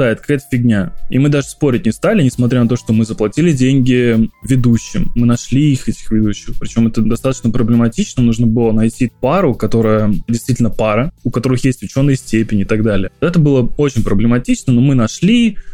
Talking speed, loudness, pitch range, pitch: 180 wpm, -14 LUFS, 110-130 Hz, 120 Hz